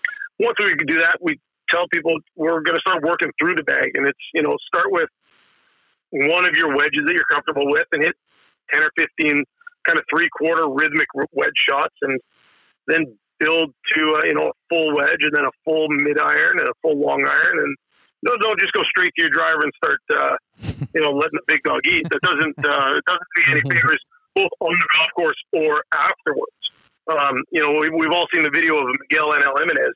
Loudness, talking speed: -18 LUFS, 215 wpm